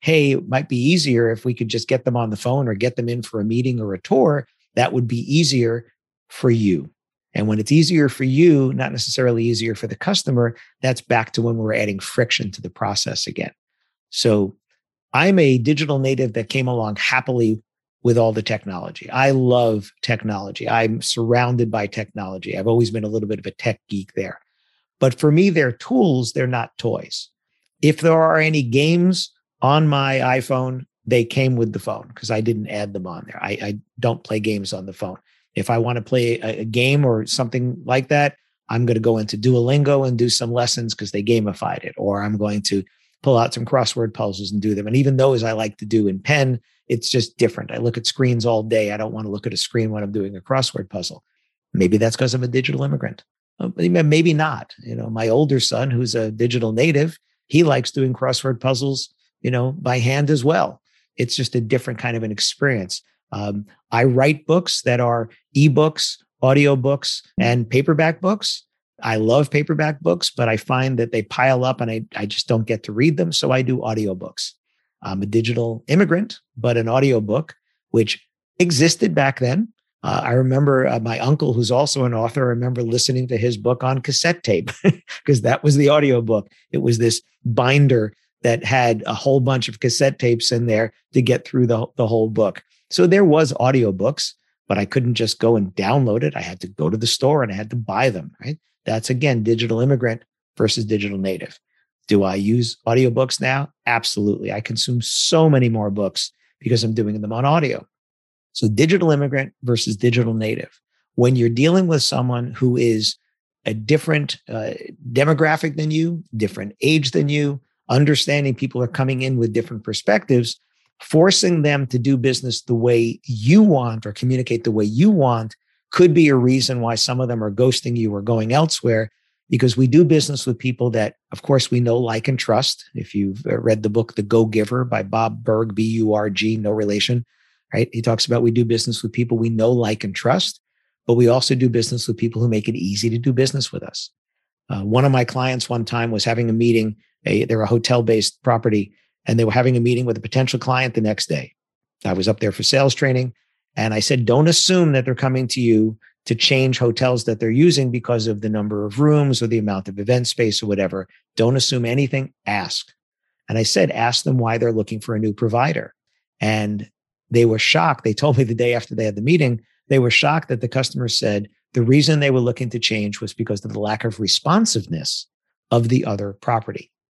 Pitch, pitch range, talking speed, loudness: 120 Hz, 110-135 Hz, 210 wpm, -19 LUFS